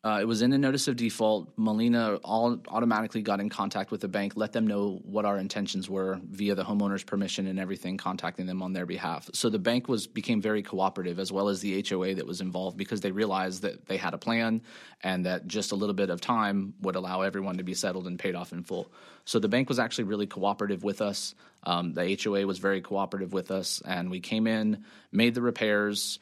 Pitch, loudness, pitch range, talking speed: 100 Hz, -30 LUFS, 95-110 Hz, 230 wpm